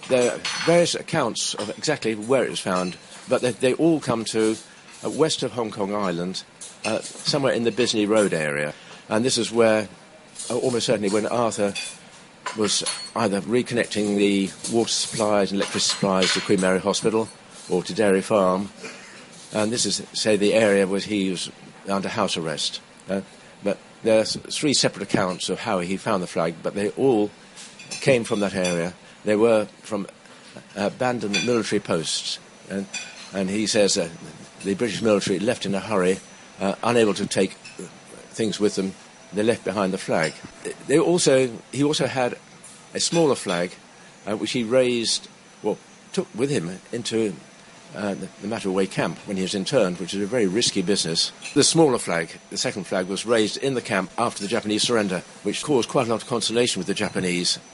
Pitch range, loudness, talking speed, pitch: 95-115 Hz, -23 LUFS, 180 wpm, 105 Hz